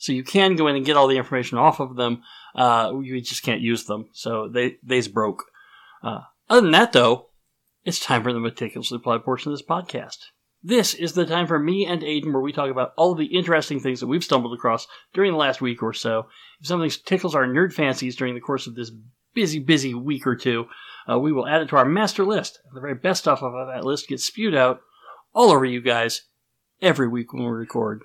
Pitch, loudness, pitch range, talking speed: 130 Hz, -21 LUFS, 120-160 Hz, 235 wpm